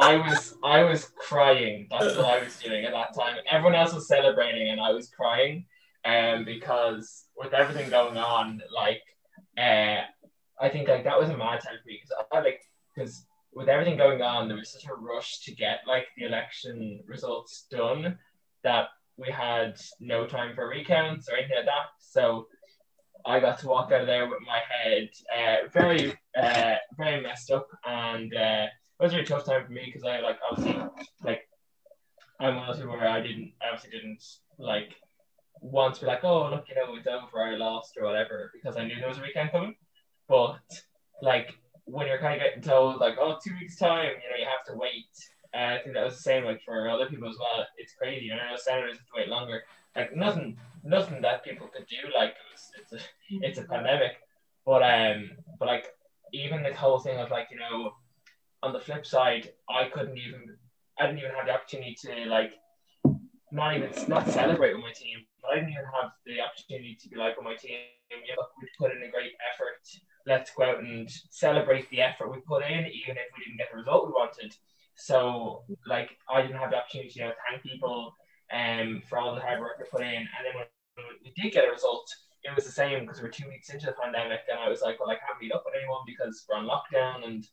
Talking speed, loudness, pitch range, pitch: 225 wpm, -28 LUFS, 115-150 Hz, 130 Hz